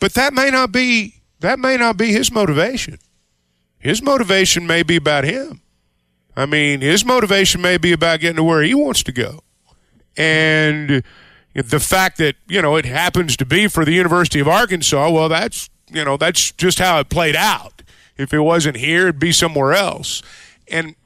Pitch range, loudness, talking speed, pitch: 145-190 Hz, -15 LUFS, 185 wpm, 165 Hz